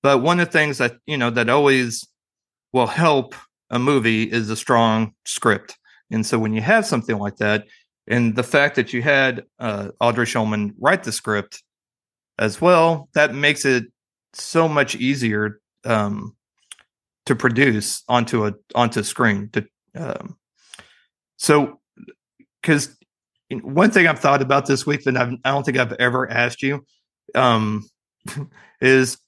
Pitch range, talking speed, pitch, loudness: 110-140 Hz, 155 wpm, 125 Hz, -19 LUFS